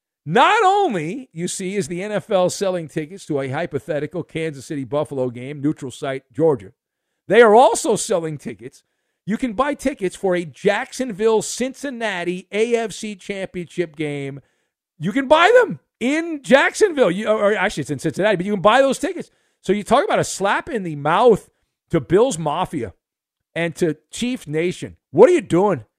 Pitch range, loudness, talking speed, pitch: 155-235 Hz, -19 LUFS, 170 wpm, 185 Hz